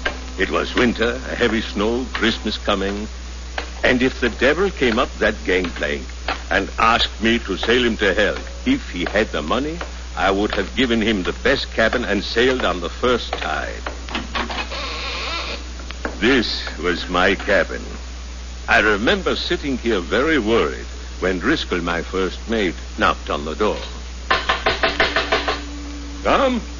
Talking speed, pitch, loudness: 140 wpm, 70 Hz, -20 LUFS